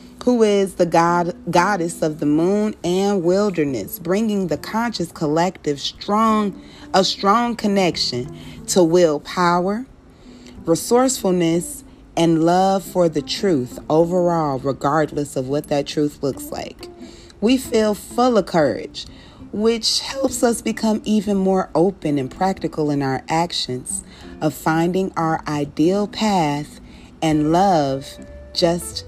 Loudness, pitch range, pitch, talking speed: -19 LUFS, 150-200 Hz, 175 Hz, 120 wpm